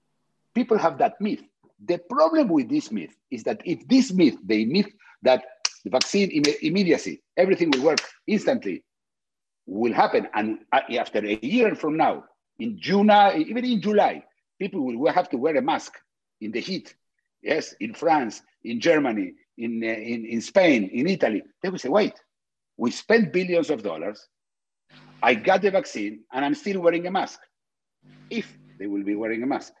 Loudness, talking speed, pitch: -23 LUFS, 170 wpm, 195 Hz